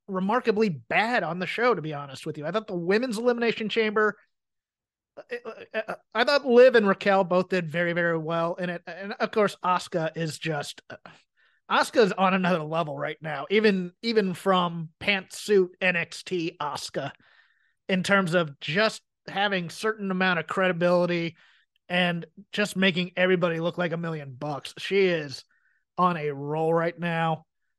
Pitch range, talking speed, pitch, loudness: 165-205 Hz, 160 wpm, 180 Hz, -25 LUFS